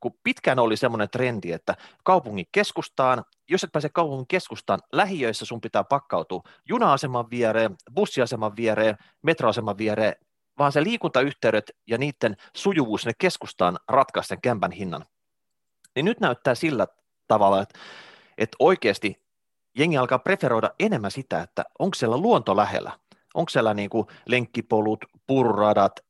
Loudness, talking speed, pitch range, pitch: -24 LUFS, 135 wpm, 110-145 Hz, 120 Hz